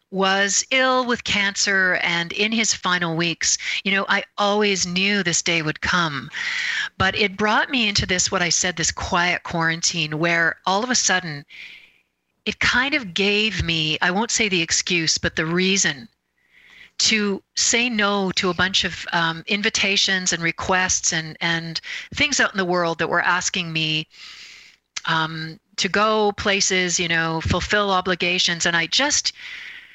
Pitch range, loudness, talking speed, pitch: 170-210 Hz, -19 LUFS, 160 wpm, 185 Hz